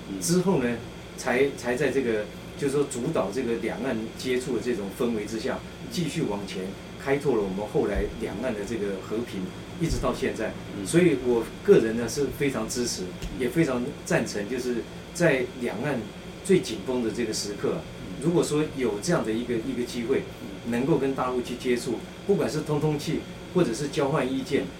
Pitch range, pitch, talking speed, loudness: 110-150 Hz, 125 Hz, 270 characters per minute, -27 LUFS